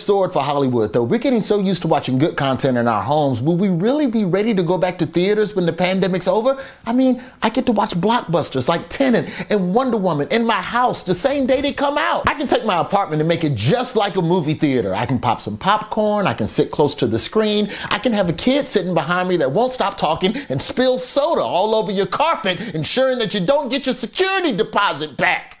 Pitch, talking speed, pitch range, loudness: 205 Hz, 240 wpm, 175-245 Hz, -18 LUFS